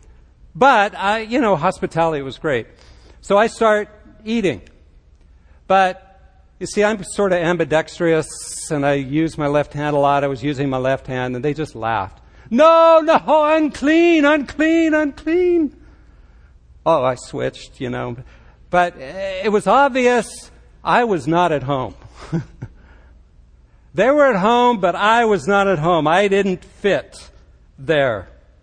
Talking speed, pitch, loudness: 145 wpm, 170 Hz, -17 LUFS